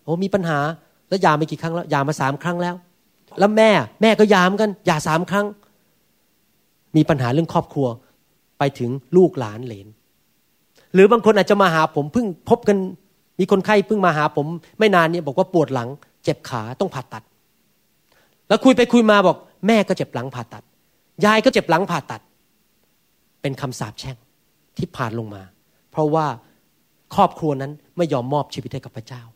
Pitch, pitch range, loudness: 160 Hz, 130-190 Hz, -19 LUFS